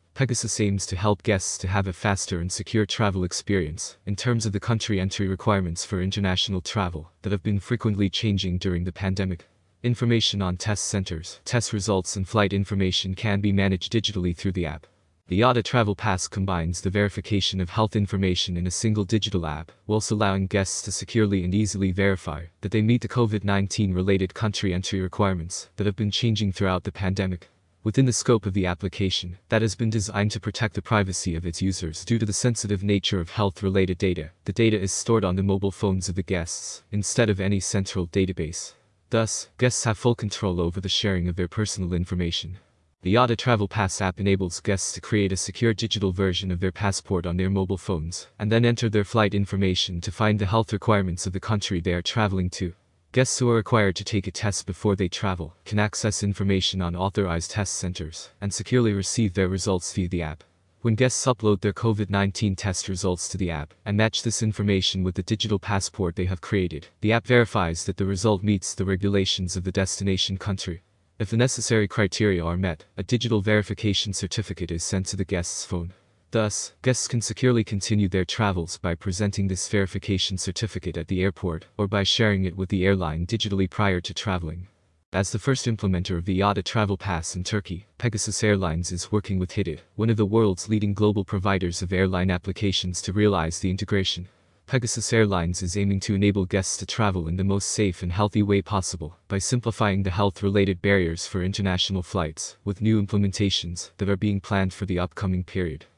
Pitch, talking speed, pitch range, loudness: 100 Hz, 200 wpm, 95-105 Hz, -25 LUFS